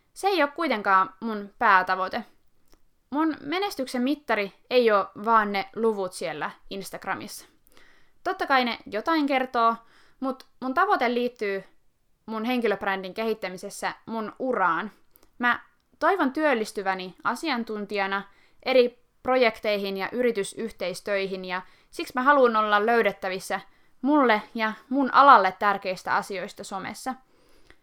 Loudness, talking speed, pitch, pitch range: -25 LUFS, 110 wpm, 225 Hz, 195-260 Hz